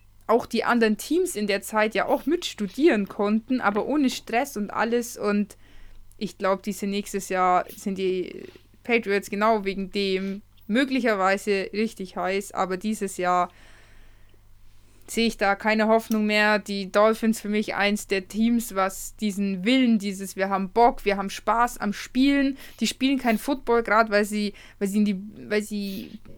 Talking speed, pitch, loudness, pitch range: 165 wpm, 205 Hz, -24 LUFS, 195-225 Hz